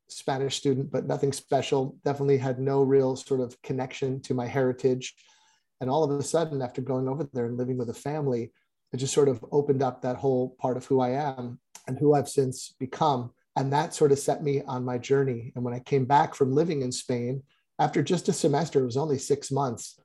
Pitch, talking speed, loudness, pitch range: 135 Hz, 220 wpm, -27 LUFS, 130-140 Hz